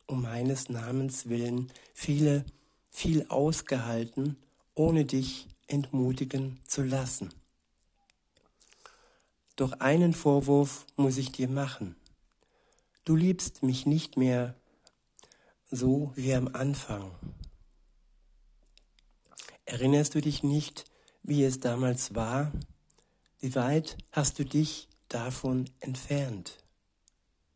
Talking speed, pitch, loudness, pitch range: 95 wpm, 130 Hz, -30 LUFS, 120-145 Hz